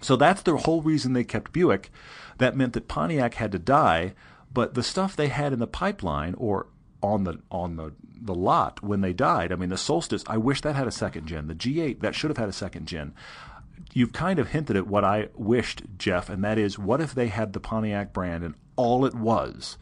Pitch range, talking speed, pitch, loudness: 95-135 Hz, 235 wpm, 110 Hz, -26 LUFS